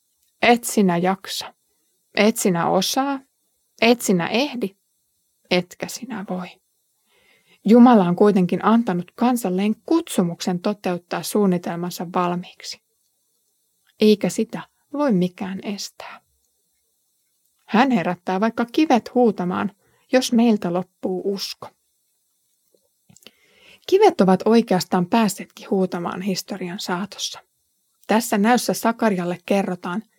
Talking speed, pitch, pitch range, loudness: 90 wpm, 205 Hz, 185-235 Hz, -20 LUFS